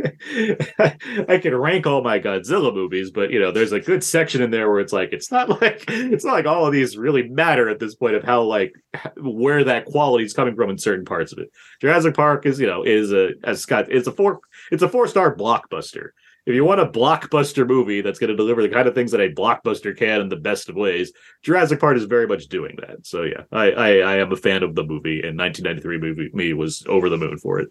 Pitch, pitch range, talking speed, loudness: 130 Hz, 105-165 Hz, 250 wpm, -19 LUFS